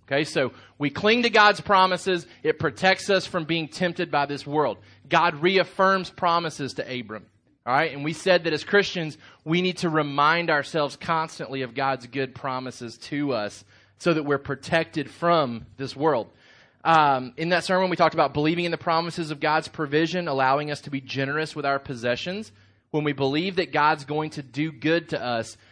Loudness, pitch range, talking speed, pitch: -24 LUFS, 135-170 Hz, 190 wpm, 155 Hz